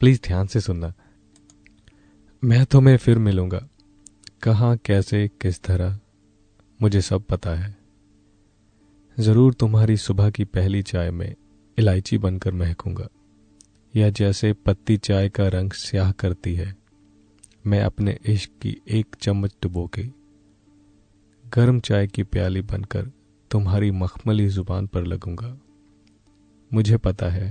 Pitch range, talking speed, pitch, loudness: 95-105 Hz, 125 wpm, 100 Hz, -22 LUFS